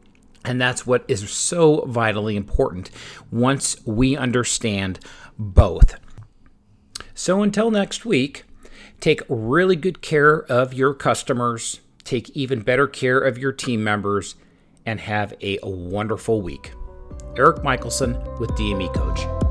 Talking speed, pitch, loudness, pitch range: 125 wpm, 120 Hz, -21 LUFS, 100-135 Hz